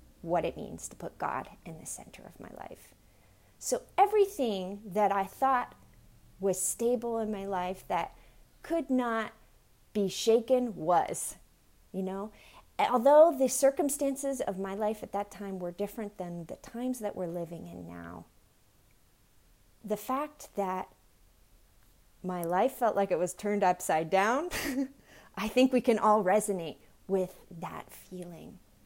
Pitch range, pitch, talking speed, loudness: 180-250 Hz, 200 Hz, 145 wpm, -30 LUFS